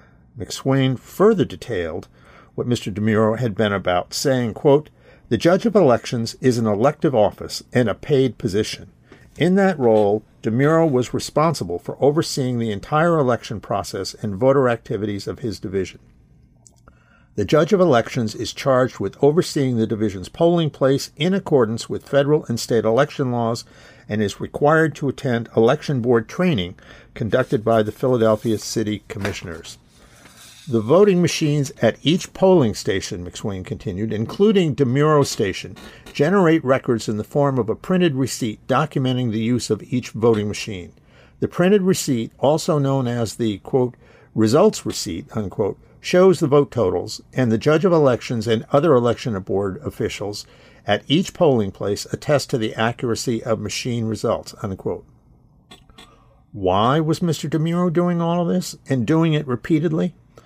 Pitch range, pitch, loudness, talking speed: 110-155 Hz, 130 Hz, -20 LUFS, 150 wpm